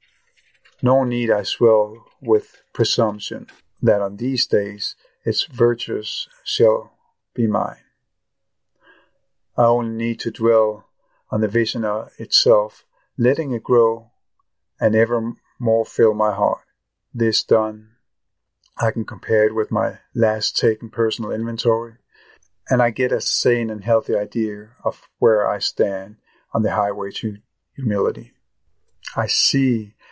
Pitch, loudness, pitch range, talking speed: 115 Hz, -20 LUFS, 110-120 Hz, 130 wpm